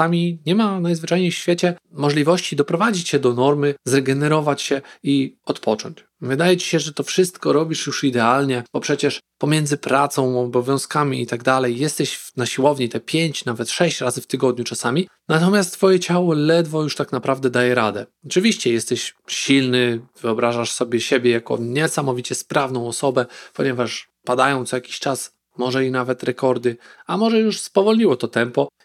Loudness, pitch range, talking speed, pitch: -20 LUFS, 125-165 Hz, 160 wpm, 140 Hz